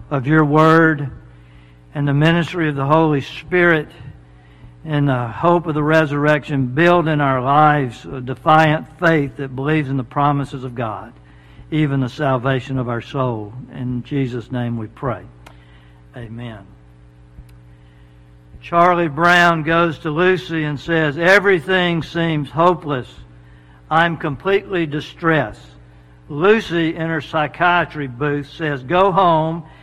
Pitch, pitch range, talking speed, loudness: 145 Hz, 115-160 Hz, 125 wpm, -17 LUFS